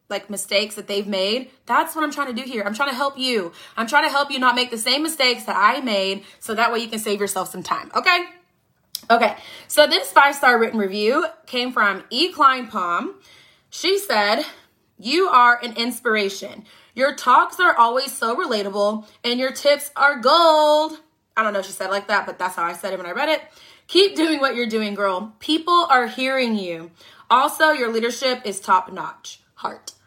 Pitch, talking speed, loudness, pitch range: 240 Hz, 210 wpm, -19 LUFS, 205-290 Hz